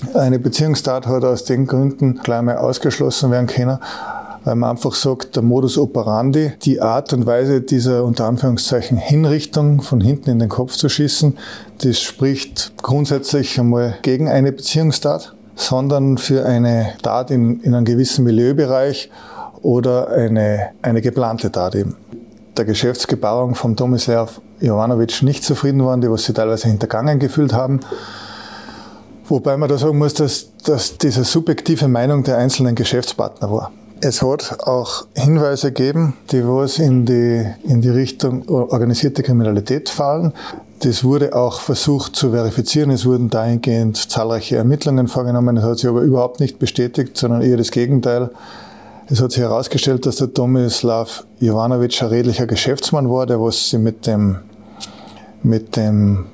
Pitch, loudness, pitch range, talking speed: 125 Hz, -16 LUFS, 120-135 Hz, 150 wpm